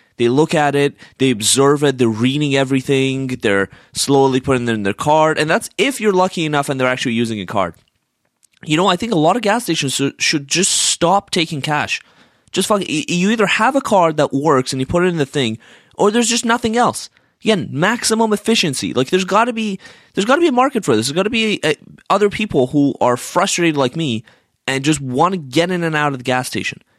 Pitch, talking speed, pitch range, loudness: 155 Hz, 235 wpm, 135-195 Hz, -16 LUFS